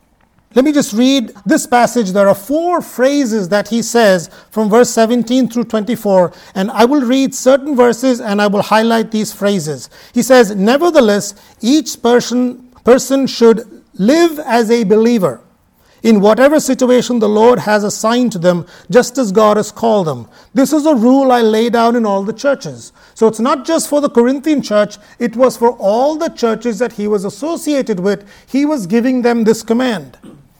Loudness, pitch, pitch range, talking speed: -13 LUFS, 235 Hz, 210-260 Hz, 180 wpm